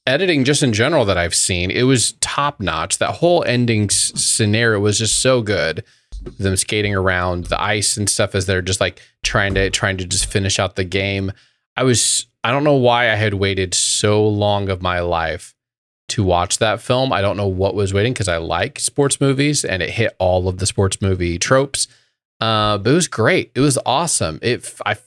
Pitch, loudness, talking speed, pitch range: 105 Hz, -17 LUFS, 210 wpm, 95-120 Hz